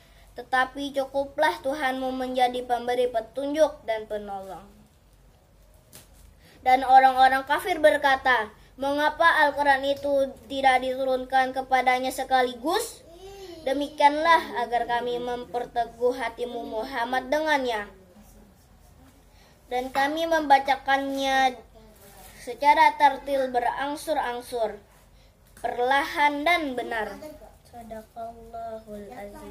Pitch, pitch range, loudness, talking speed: 260 Hz, 235-280 Hz, -24 LUFS, 75 wpm